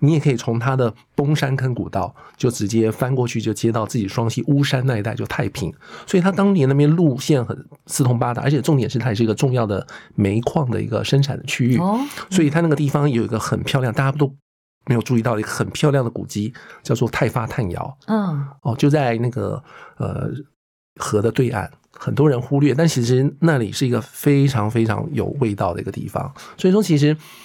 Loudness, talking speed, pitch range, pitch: -20 LUFS, 320 characters per minute, 115-145 Hz, 130 Hz